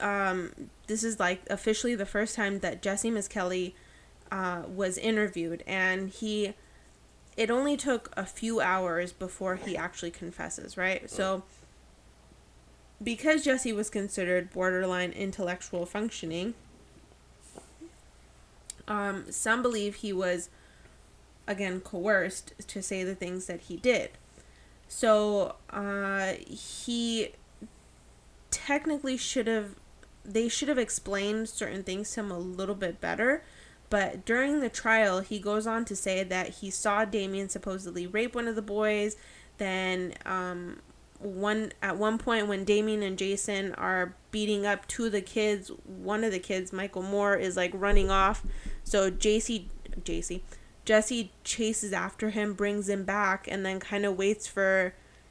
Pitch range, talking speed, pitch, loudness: 185-215 Hz, 140 wpm, 200 Hz, -30 LUFS